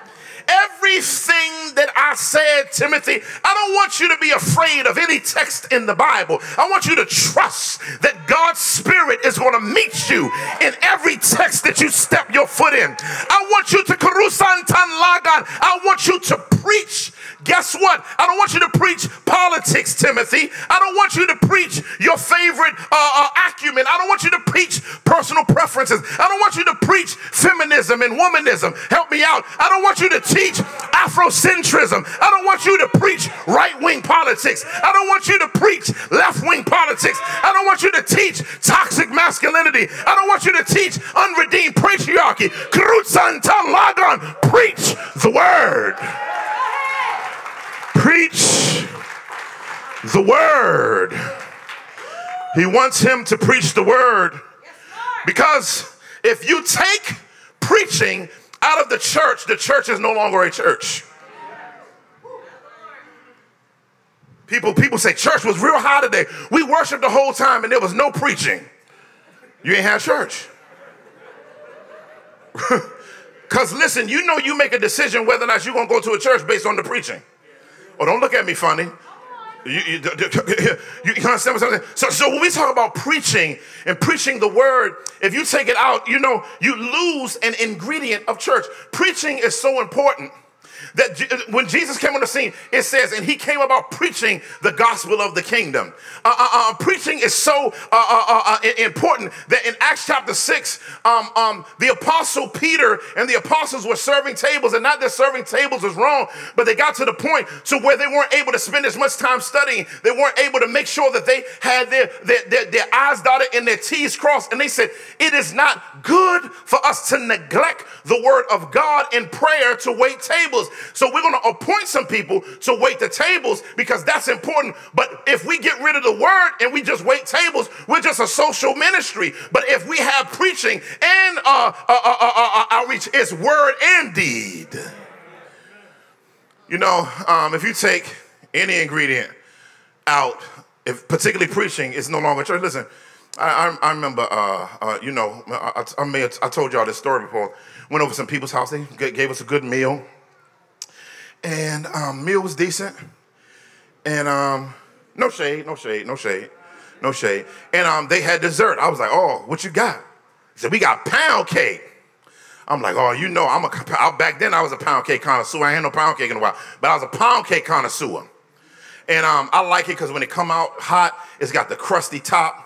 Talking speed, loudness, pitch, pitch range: 180 wpm, -16 LUFS, 320 Hz, 250-410 Hz